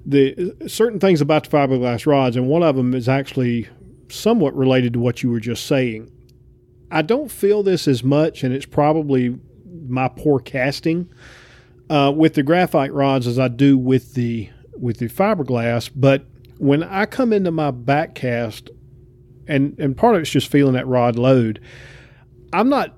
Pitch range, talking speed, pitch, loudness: 125-155 Hz, 170 wpm, 135 Hz, -18 LUFS